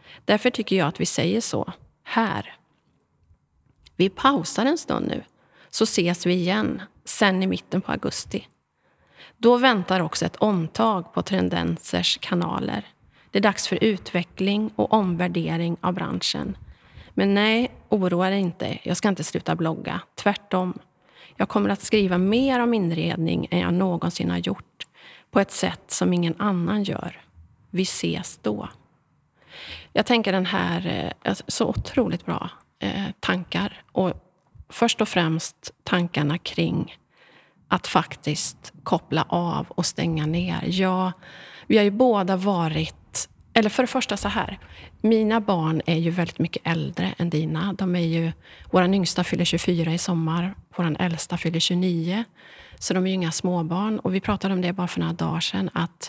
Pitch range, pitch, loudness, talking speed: 165-205 Hz, 180 Hz, -23 LUFS, 150 wpm